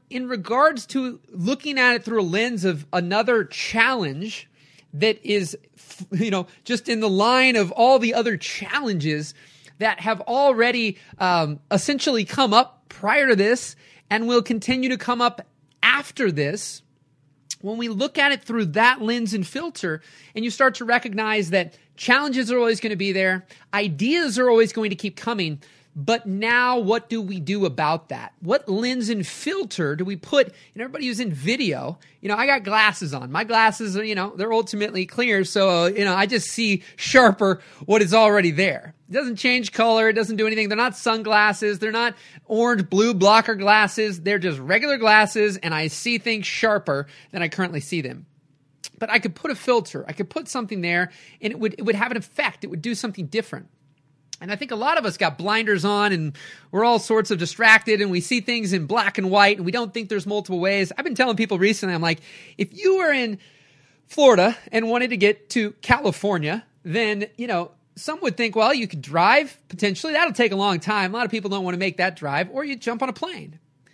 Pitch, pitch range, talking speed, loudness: 210 Hz, 180-235 Hz, 205 wpm, -21 LUFS